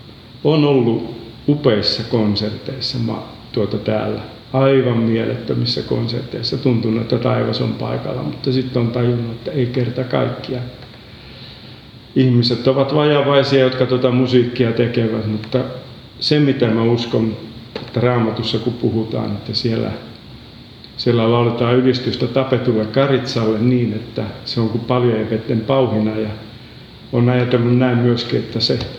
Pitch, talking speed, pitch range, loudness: 120 Hz, 125 wpm, 115-130 Hz, -17 LUFS